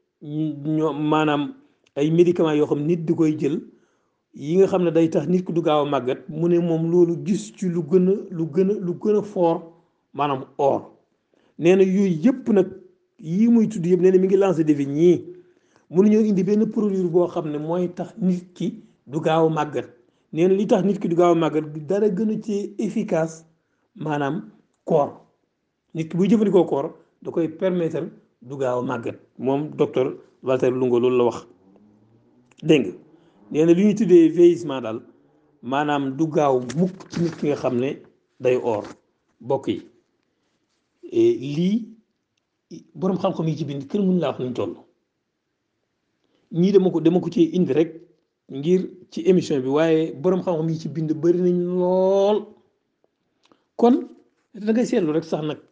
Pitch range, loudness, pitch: 150-190 Hz, -21 LUFS, 170 Hz